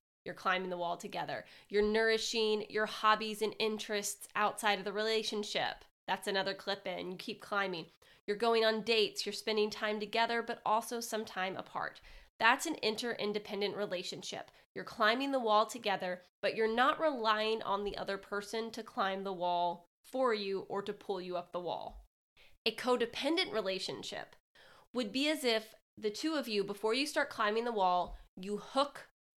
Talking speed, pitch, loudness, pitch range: 170 wpm, 215 Hz, -35 LUFS, 195-230 Hz